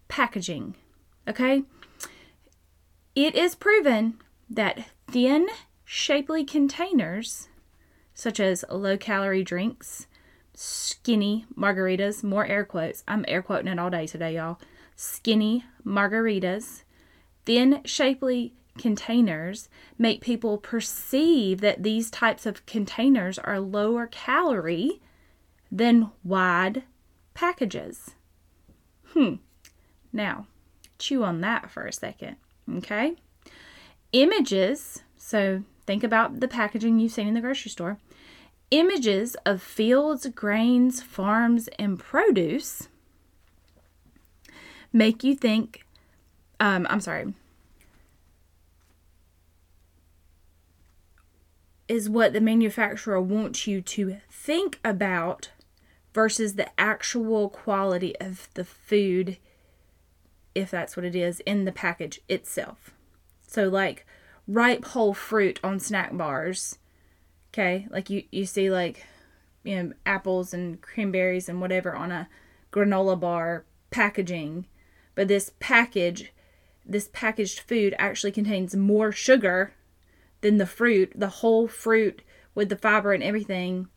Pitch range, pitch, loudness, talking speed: 175-230 Hz, 200 Hz, -25 LUFS, 110 wpm